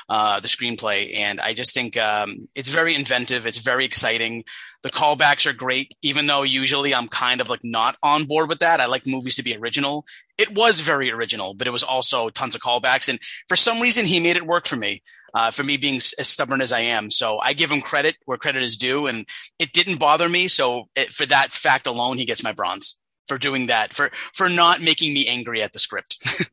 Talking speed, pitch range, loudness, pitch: 235 wpm, 120-160 Hz, -19 LUFS, 140 Hz